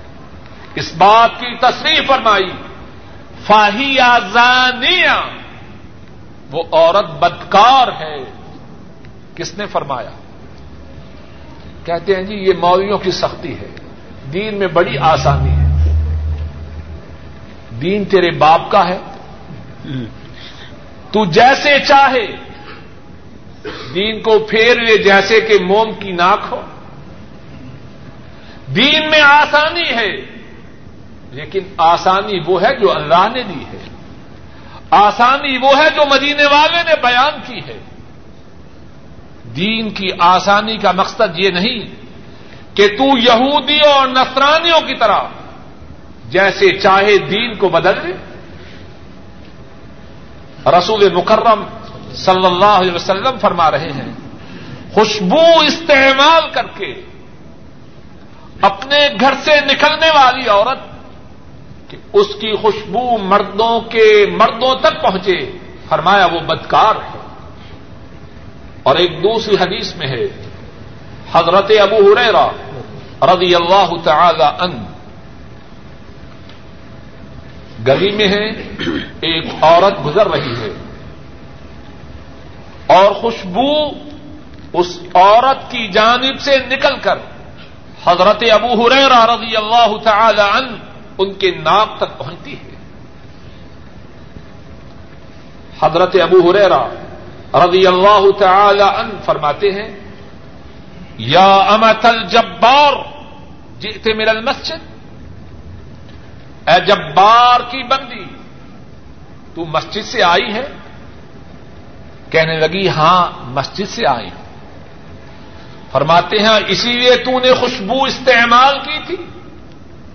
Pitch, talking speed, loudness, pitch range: 205 Hz, 100 wpm, -11 LUFS, 175-250 Hz